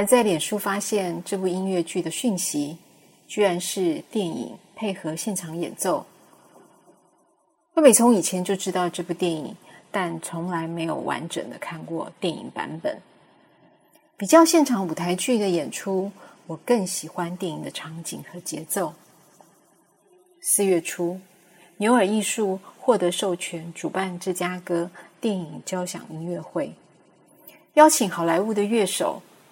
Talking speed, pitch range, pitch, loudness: 210 characters per minute, 175-220 Hz, 185 Hz, -24 LUFS